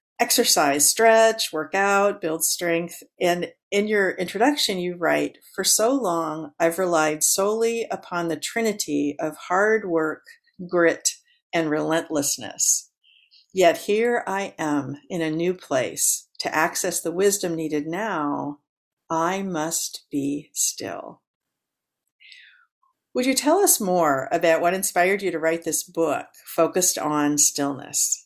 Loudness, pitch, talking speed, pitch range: -22 LUFS, 175 Hz, 130 wpm, 155-205 Hz